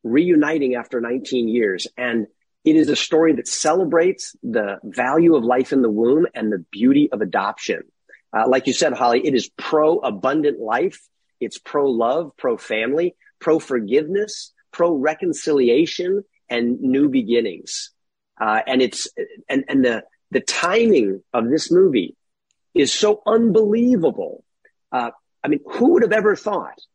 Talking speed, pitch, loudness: 140 wpm, 180 Hz, -19 LUFS